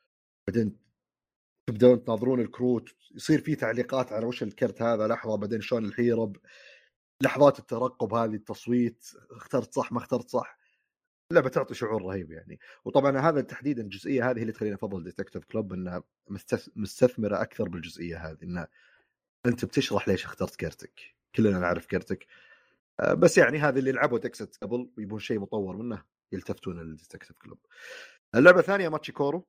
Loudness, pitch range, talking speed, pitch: -27 LUFS, 105-130 Hz, 140 wpm, 115 Hz